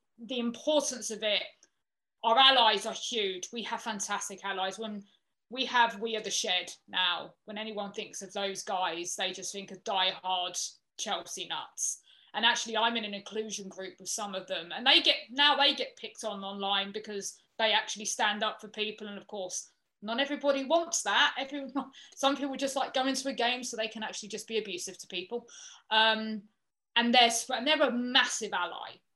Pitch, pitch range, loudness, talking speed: 220 Hz, 200-260 Hz, -29 LUFS, 190 wpm